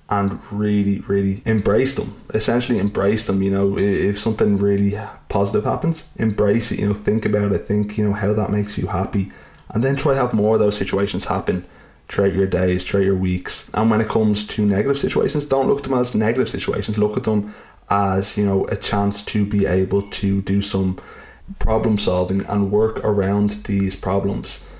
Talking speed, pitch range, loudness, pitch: 195 wpm, 100-110 Hz, -20 LUFS, 100 Hz